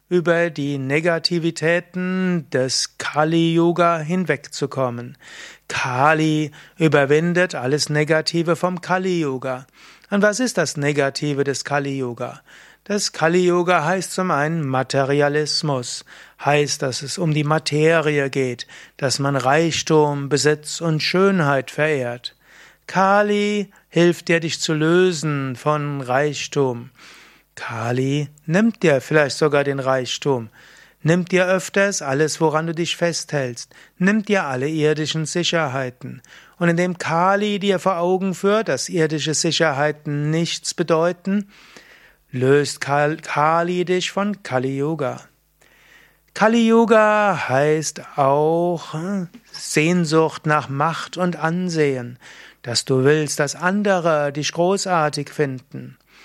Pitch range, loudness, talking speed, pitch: 140-175 Hz, -19 LUFS, 115 wpm, 155 Hz